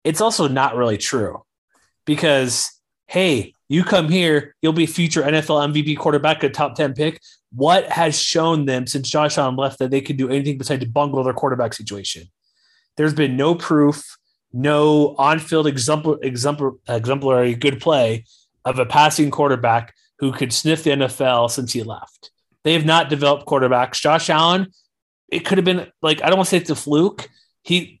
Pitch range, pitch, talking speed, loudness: 130-155 Hz, 145 Hz, 180 wpm, -18 LUFS